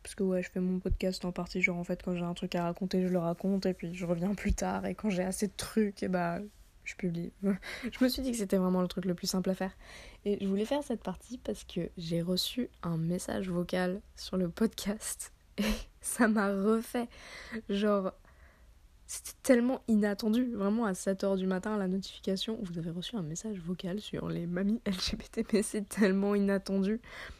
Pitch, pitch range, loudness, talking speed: 195 Hz, 185-215 Hz, -33 LUFS, 210 wpm